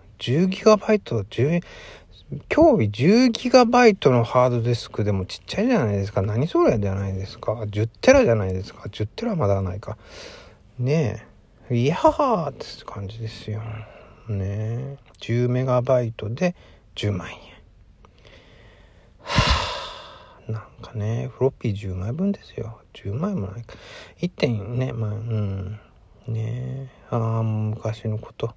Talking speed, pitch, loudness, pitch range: 230 characters per minute, 110 Hz, -22 LUFS, 105-125 Hz